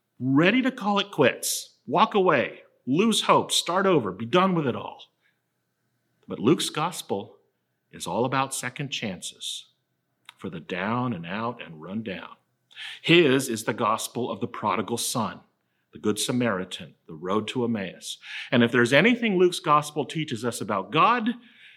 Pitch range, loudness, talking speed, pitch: 120-190 Hz, -24 LUFS, 155 wpm, 135 Hz